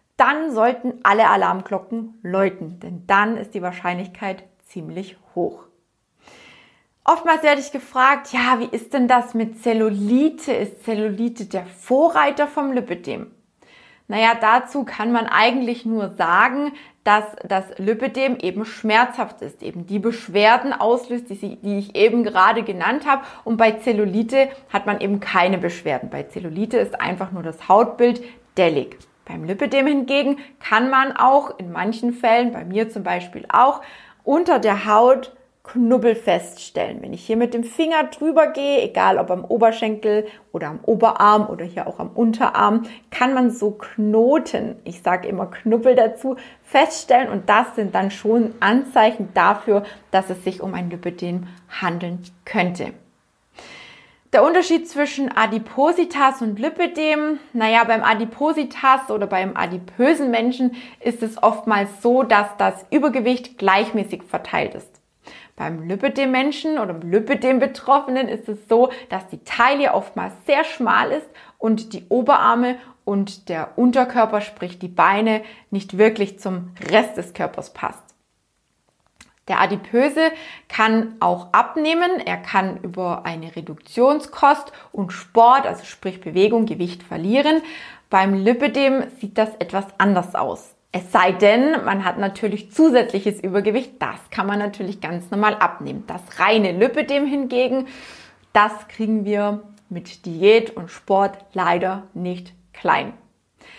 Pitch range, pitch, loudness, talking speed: 195-255 Hz, 225 Hz, -19 LUFS, 140 wpm